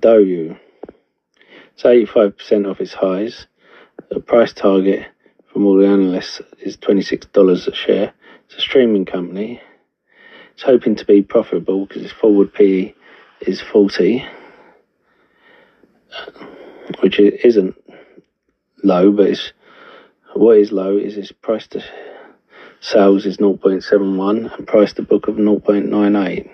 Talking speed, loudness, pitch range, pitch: 120 wpm, -15 LUFS, 100-105 Hz, 100 Hz